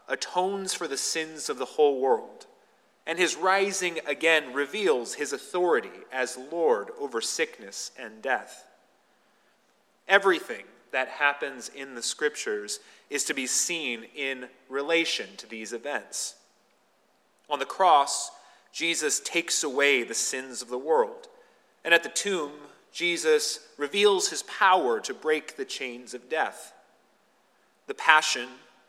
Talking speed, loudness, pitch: 130 wpm, -26 LUFS, 165 Hz